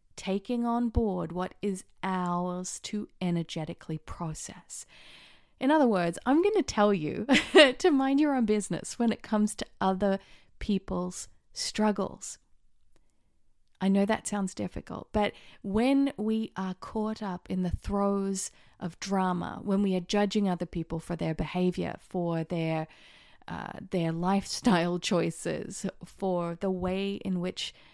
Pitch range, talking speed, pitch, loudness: 180-215 Hz, 140 wpm, 195 Hz, -29 LUFS